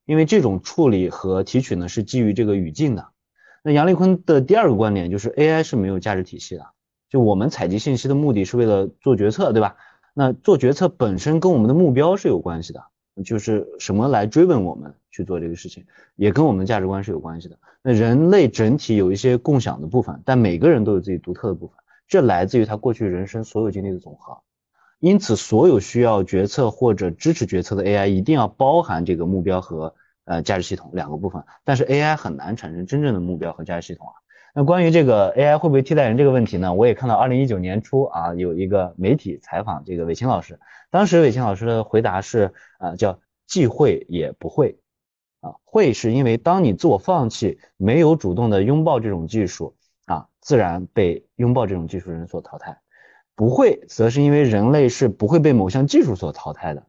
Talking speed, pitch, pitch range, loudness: 335 characters per minute, 110 Hz, 95-135 Hz, -19 LUFS